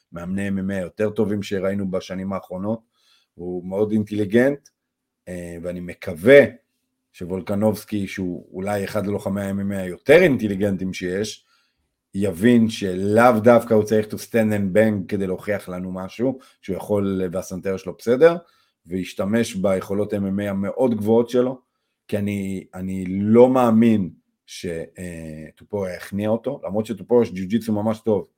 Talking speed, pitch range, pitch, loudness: 125 wpm, 95-110 Hz, 100 Hz, -21 LUFS